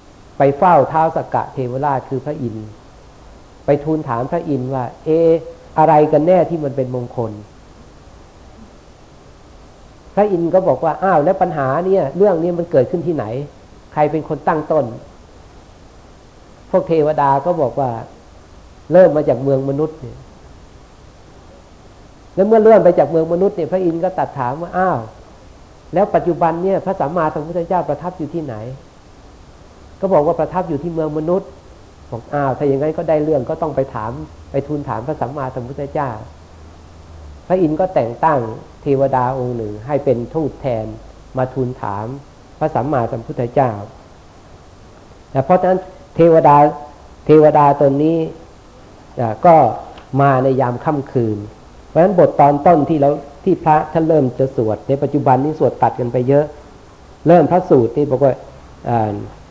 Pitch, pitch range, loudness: 140 Hz, 115-160 Hz, -16 LUFS